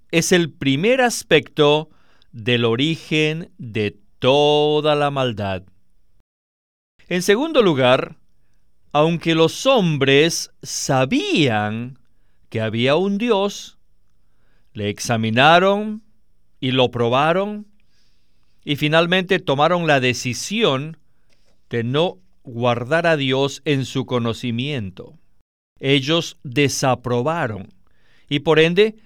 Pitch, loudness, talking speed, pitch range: 140 Hz, -18 LUFS, 90 wpm, 120-165 Hz